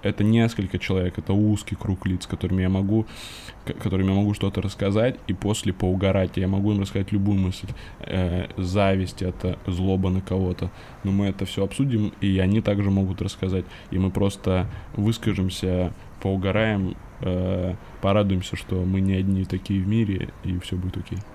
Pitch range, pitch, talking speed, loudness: 95-105 Hz, 95 Hz, 165 wpm, -24 LUFS